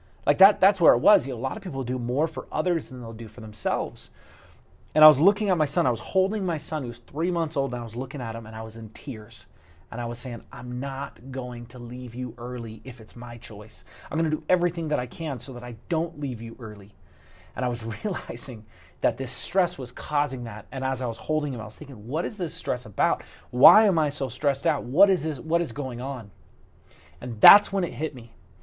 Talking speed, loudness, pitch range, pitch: 255 wpm, -25 LUFS, 115-155 Hz, 125 Hz